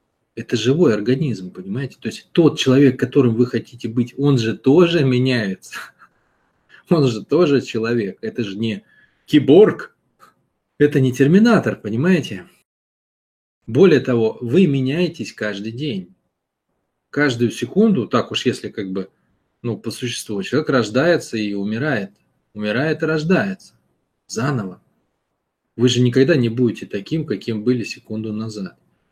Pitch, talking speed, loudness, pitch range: 125 Hz, 130 wpm, -18 LUFS, 110-145 Hz